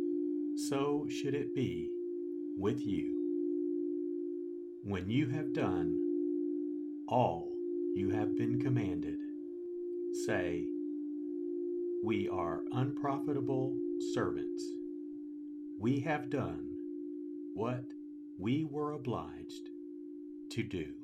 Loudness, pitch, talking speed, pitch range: -37 LUFS, 315 Hz, 85 wpm, 300-335 Hz